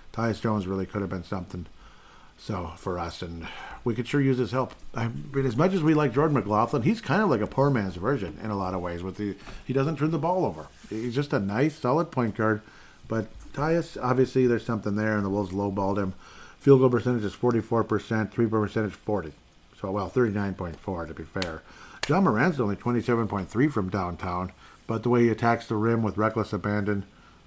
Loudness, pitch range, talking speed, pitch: -27 LUFS, 100-125 Hz, 220 wpm, 110 Hz